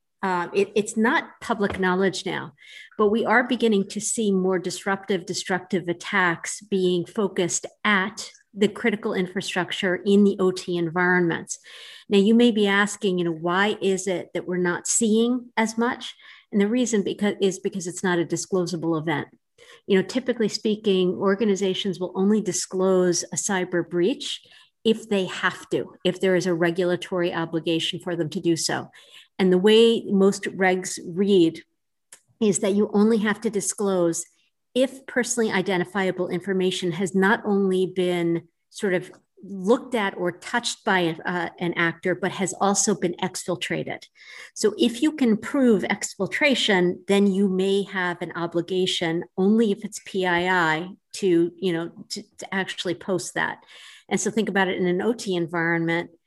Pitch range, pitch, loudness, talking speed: 180-210 Hz, 190 Hz, -23 LUFS, 160 wpm